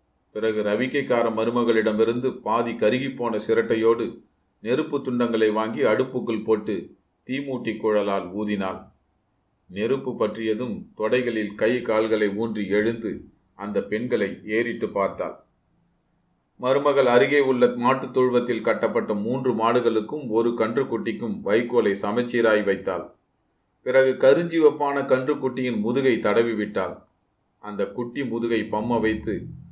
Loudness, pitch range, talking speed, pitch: -23 LUFS, 110-125 Hz, 100 wpm, 115 Hz